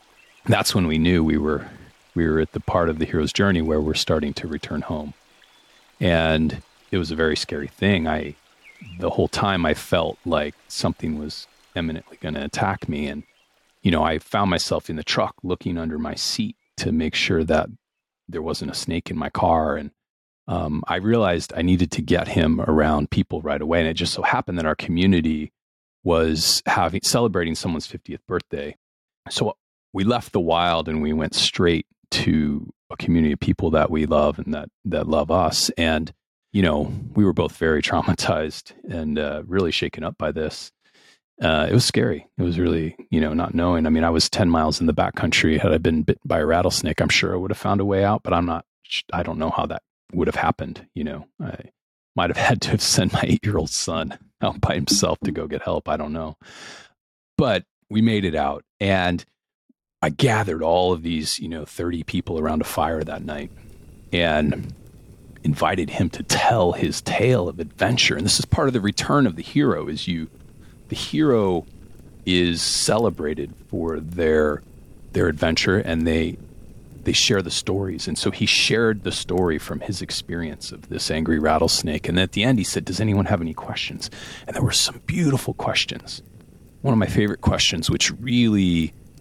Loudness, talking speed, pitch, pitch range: -22 LUFS, 200 wpm, 85 Hz, 80-95 Hz